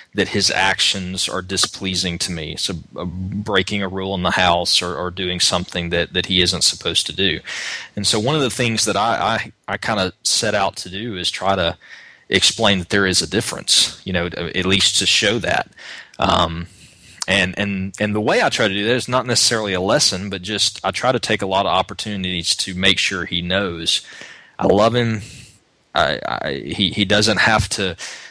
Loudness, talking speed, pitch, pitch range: -18 LUFS, 210 wpm, 95 Hz, 90-105 Hz